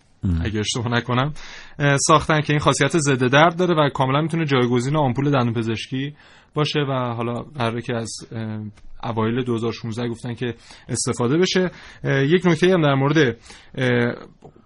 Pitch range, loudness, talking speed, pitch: 115-150 Hz, -20 LUFS, 140 wpm, 130 Hz